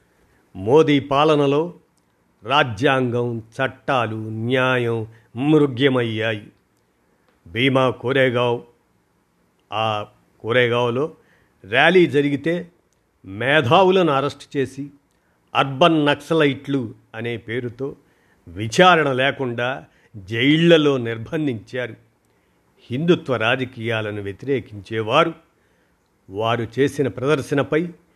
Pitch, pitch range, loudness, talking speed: 130 Hz, 115-145 Hz, -19 LUFS, 60 wpm